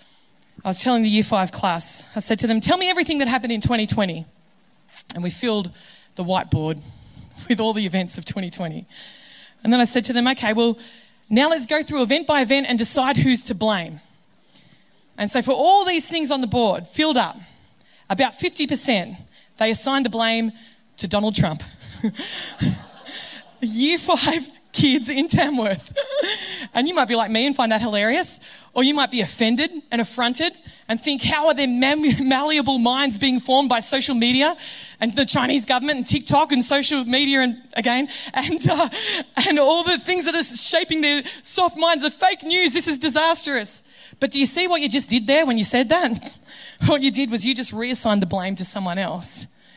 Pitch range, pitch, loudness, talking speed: 220-290 Hz, 250 Hz, -19 LUFS, 190 wpm